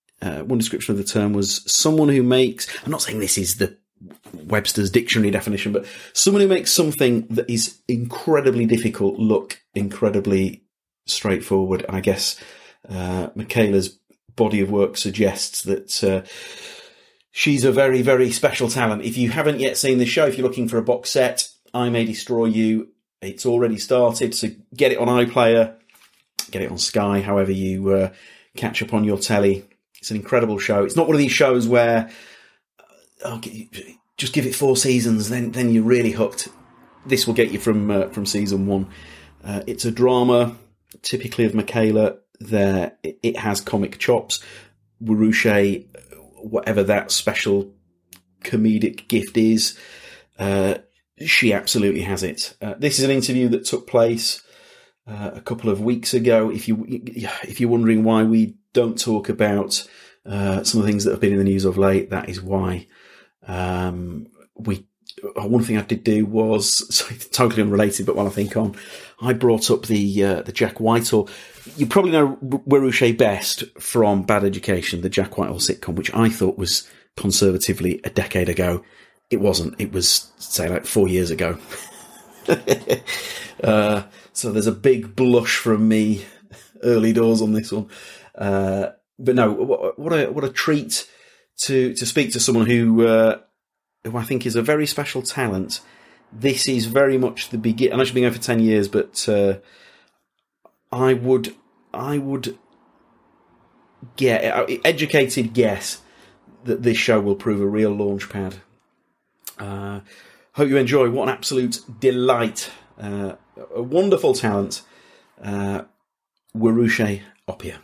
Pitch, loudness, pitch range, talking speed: 110 Hz, -20 LUFS, 100-125 Hz, 160 wpm